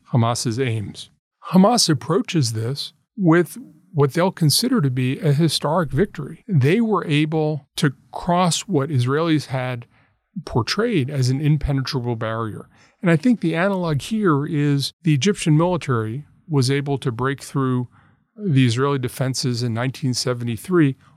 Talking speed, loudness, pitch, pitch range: 135 wpm, -20 LUFS, 145 Hz, 130-165 Hz